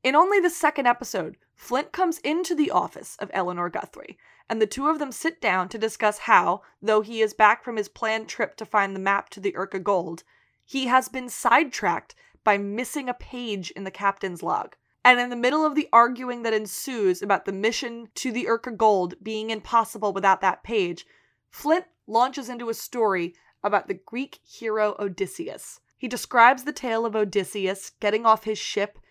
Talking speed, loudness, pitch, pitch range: 190 wpm, -24 LUFS, 220 Hz, 200-250 Hz